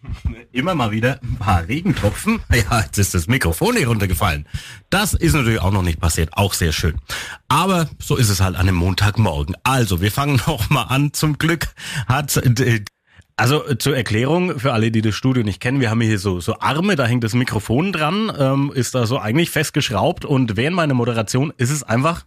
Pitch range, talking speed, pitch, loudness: 105-145 Hz, 195 wpm, 125 Hz, -18 LUFS